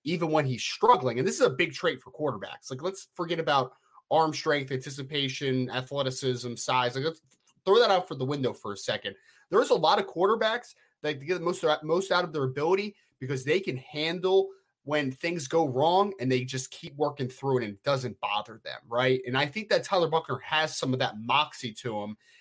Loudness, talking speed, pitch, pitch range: -28 LUFS, 215 wpm, 150 Hz, 130-170 Hz